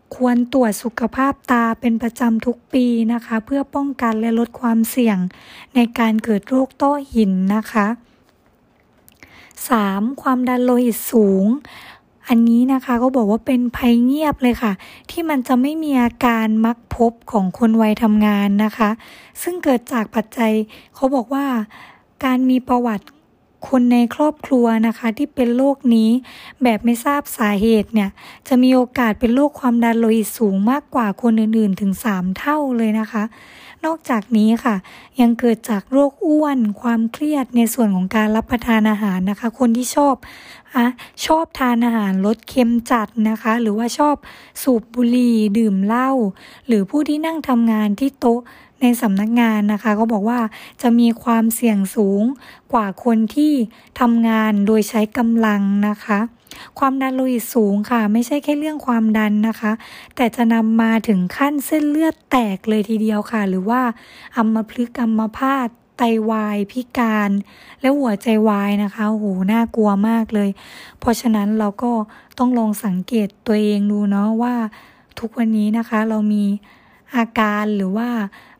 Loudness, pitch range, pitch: -18 LUFS, 215-250 Hz, 230 Hz